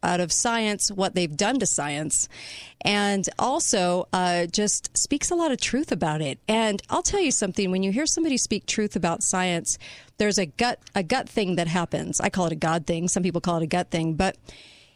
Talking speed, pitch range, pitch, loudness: 215 wpm, 175-230 Hz, 195 Hz, -24 LUFS